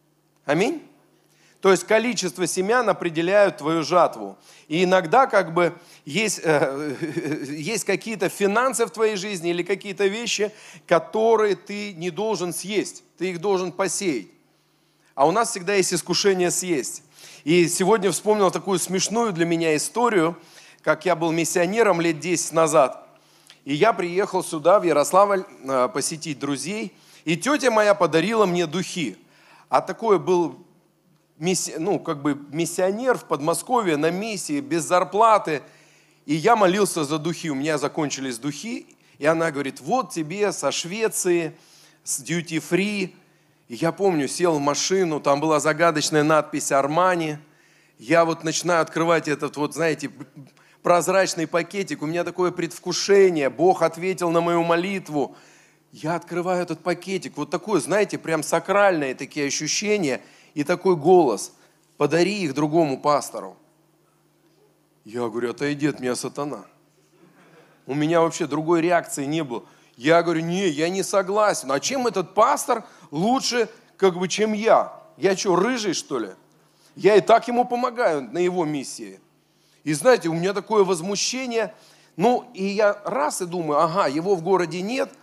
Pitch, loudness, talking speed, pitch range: 175 Hz, -22 LUFS, 145 wpm, 155-195 Hz